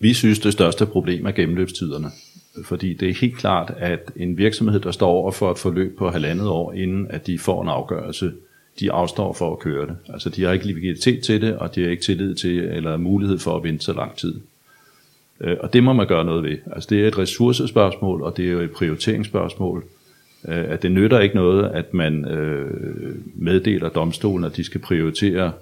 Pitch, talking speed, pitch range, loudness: 90 Hz, 205 wpm, 85-100 Hz, -21 LUFS